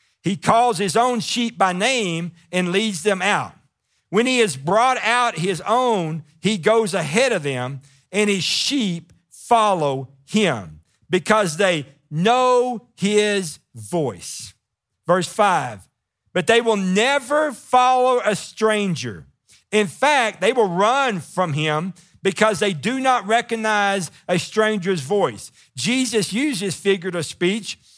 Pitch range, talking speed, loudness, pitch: 160-225 Hz, 130 wpm, -20 LUFS, 195 Hz